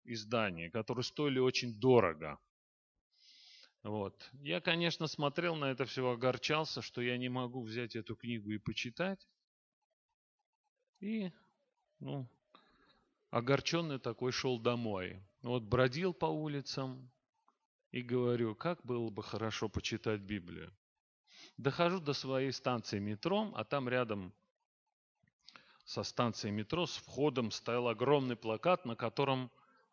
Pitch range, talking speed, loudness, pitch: 115-145 Hz, 115 wpm, -37 LUFS, 125 Hz